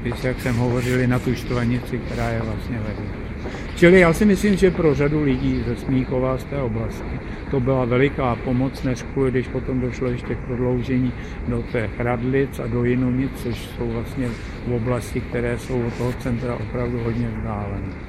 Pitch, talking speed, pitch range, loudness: 125 Hz, 180 wpm, 120-130 Hz, -22 LUFS